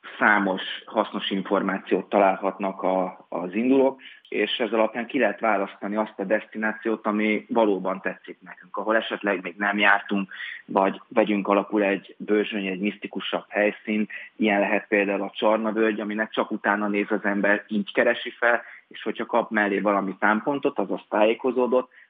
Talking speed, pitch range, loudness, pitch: 150 wpm, 100-110 Hz, -24 LUFS, 105 Hz